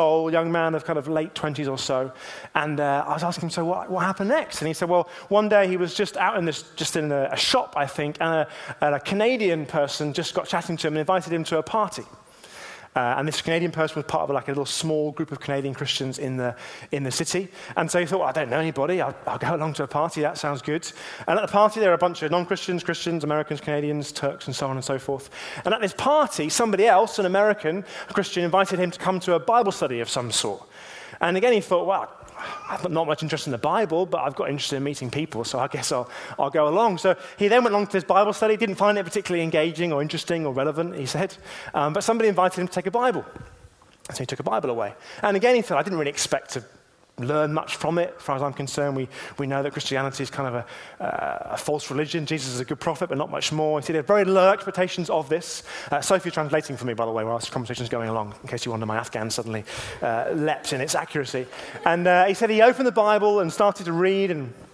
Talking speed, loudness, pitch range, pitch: 265 wpm, -24 LUFS, 140-185 Hz, 160 Hz